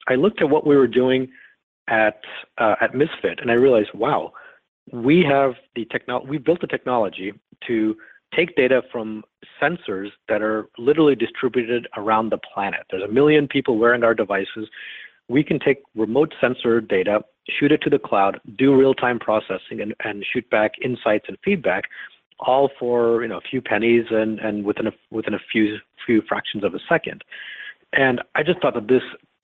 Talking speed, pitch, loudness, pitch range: 180 wpm, 120 Hz, -20 LUFS, 110-135 Hz